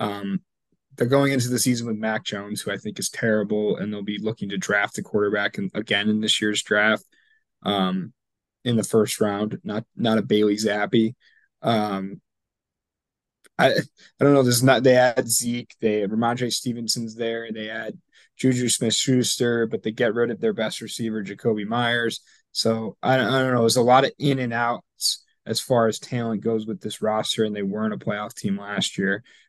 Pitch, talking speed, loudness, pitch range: 115 Hz, 195 wpm, -23 LUFS, 105-125 Hz